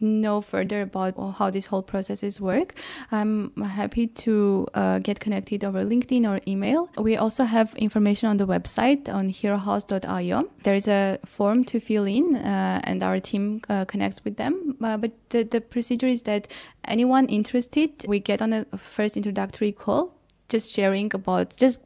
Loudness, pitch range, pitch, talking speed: -24 LUFS, 200-235 Hz, 210 Hz, 170 wpm